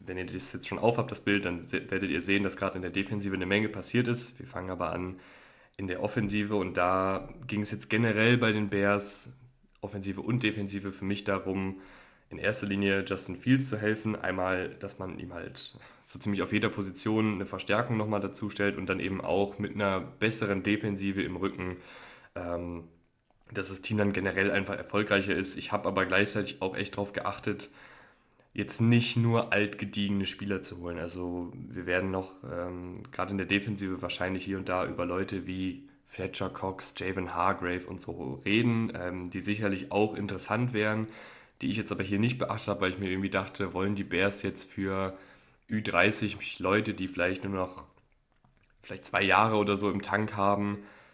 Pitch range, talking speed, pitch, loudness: 95-105 Hz, 190 wpm, 100 Hz, -31 LUFS